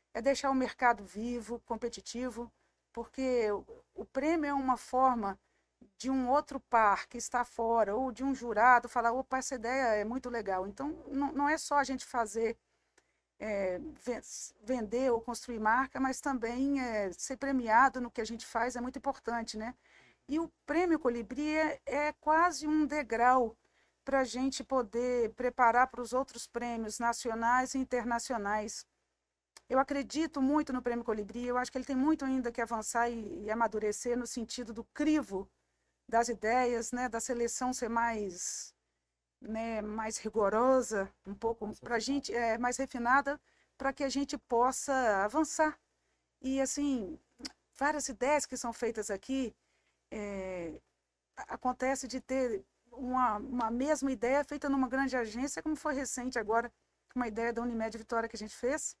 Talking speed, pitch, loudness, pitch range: 155 wpm, 245 Hz, -33 LUFS, 230-270 Hz